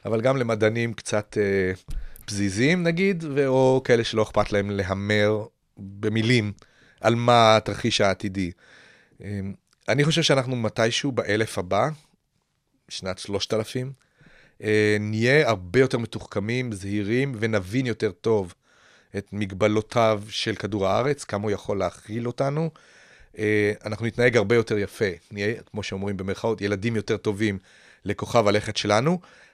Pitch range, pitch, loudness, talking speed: 100-120 Hz, 110 Hz, -24 LUFS, 130 wpm